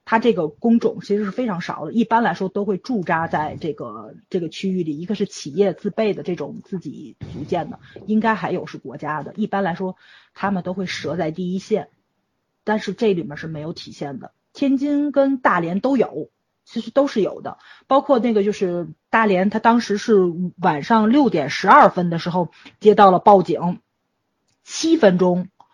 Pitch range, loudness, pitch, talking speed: 175-225 Hz, -19 LUFS, 200 Hz, 275 characters per minute